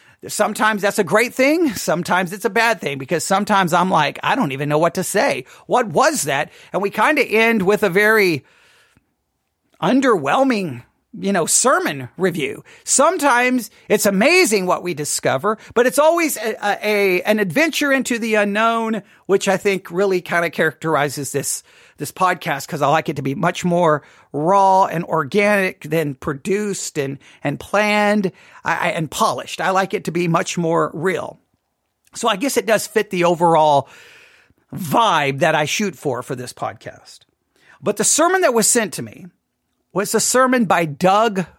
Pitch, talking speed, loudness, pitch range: 195 Hz, 175 wpm, -17 LUFS, 165-220 Hz